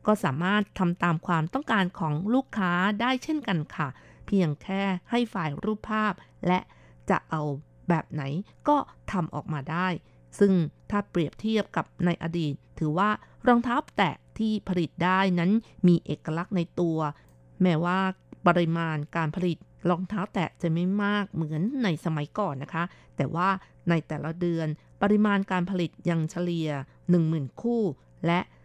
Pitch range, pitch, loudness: 160-200 Hz, 175 Hz, -27 LUFS